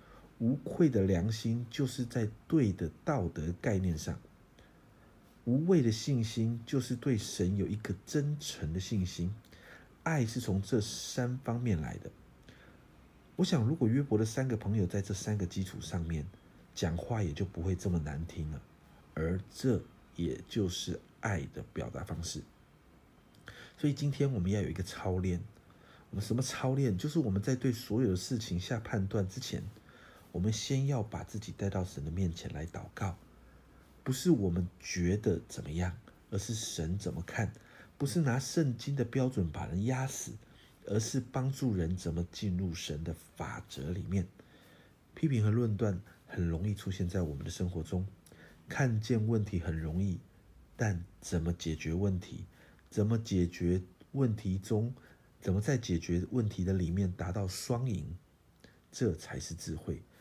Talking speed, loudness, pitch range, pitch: 230 characters per minute, -35 LUFS, 85-120 Hz, 100 Hz